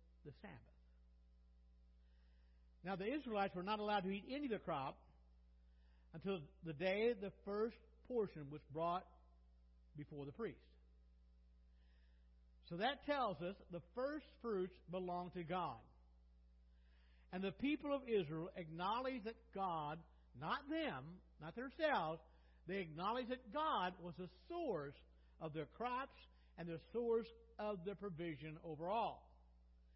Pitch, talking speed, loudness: 165 Hz, 130 wpm, -45 LUFS